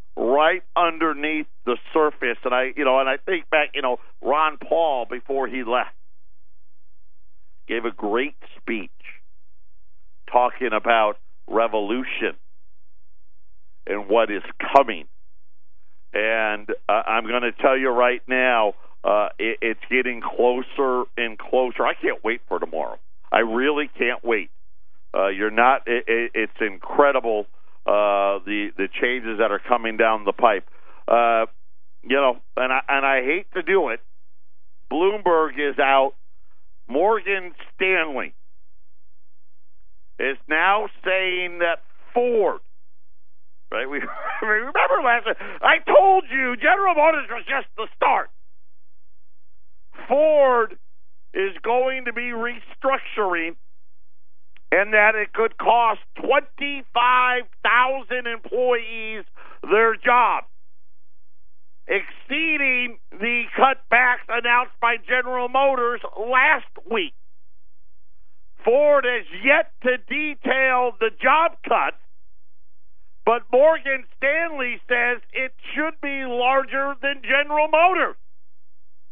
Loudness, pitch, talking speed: -21 LUFS, 190 Hz, 115 wpm